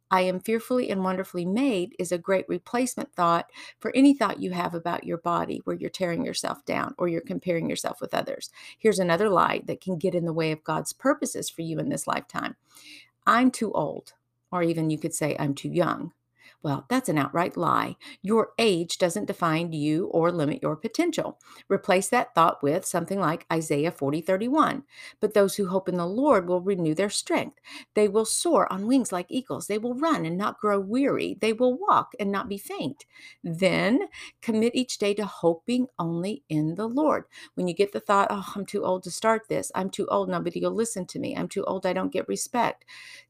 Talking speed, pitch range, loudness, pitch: 210 wpm, 170-225 Hz, -26 LUFS, 190 Hz